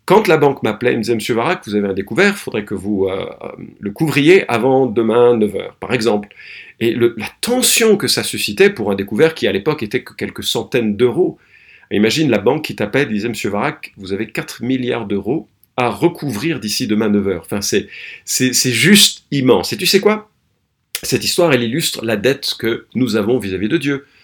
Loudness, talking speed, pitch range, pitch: -16 LUFS, 210 wpm, 110-160 Hz, 125 Hz